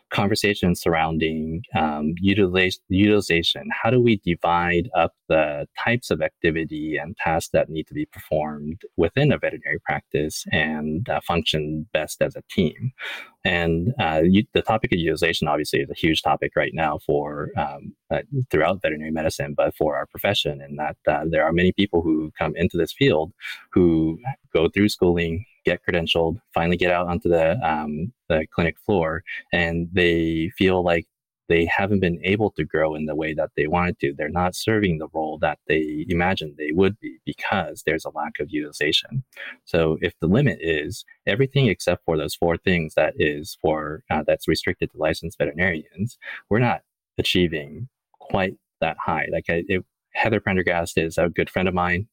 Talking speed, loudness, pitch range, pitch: 175 wpm, -22 LUFS, 80-95 Hz, 85 Hz